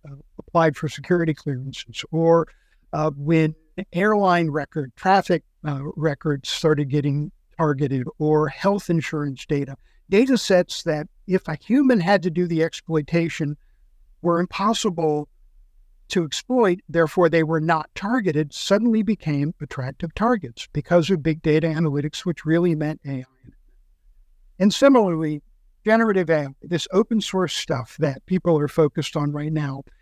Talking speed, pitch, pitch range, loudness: 135 wpm, 160 Hz, 150-180 Hz, -22 LUFS